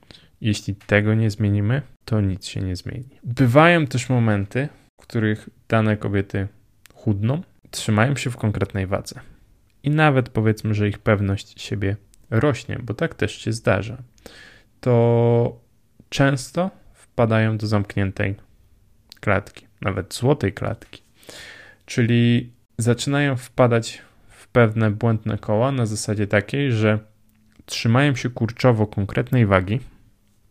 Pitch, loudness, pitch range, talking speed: 110 Hz, -21 LUFS, 105-125 Hz, 120 wpm